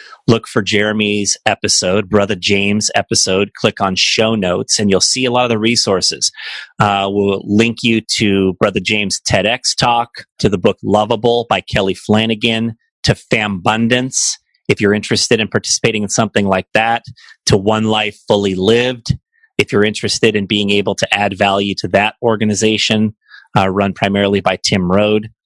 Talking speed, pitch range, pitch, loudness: 165 wpm, 100-115 Hz, 105 Hz, -14 LUFS